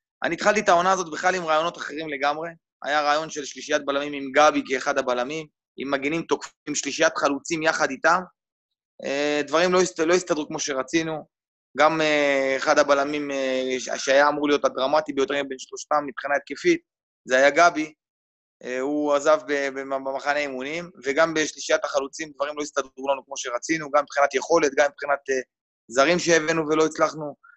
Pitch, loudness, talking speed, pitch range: 145 Hz, -23 LUFS, 150 wpm, 140-160 Hz